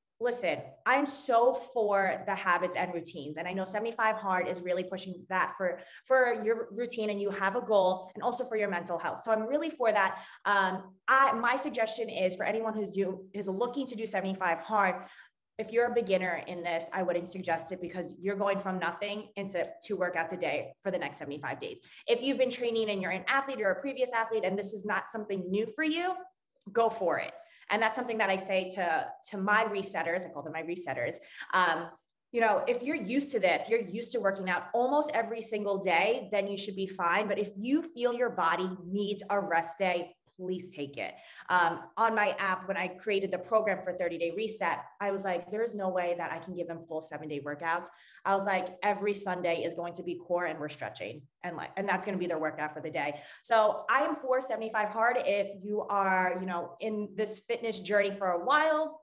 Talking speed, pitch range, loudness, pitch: 225 wpm, 180-230 Hz, -31 LUFS, 200 Hz